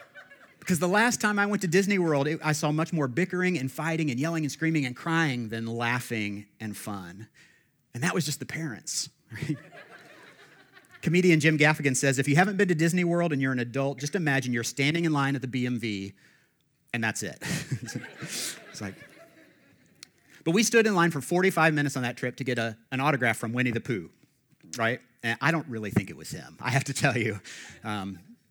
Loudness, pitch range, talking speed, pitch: -27 LUFS, 120-165 Hz, 205 wpm, 140 Hz